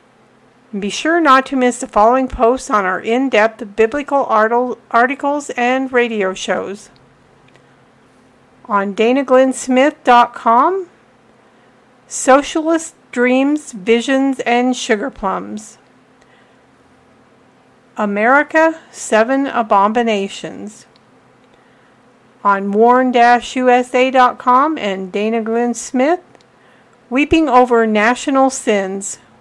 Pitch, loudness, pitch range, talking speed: 245 Hz, -14 LUFS, 220-265 Hz, 80 wpm